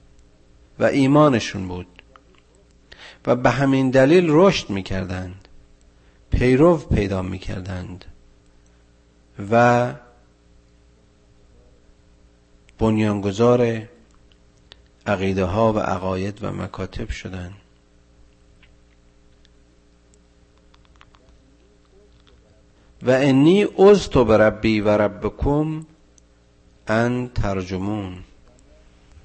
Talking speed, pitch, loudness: 60 wpm, 90 Hz, -19 LUFS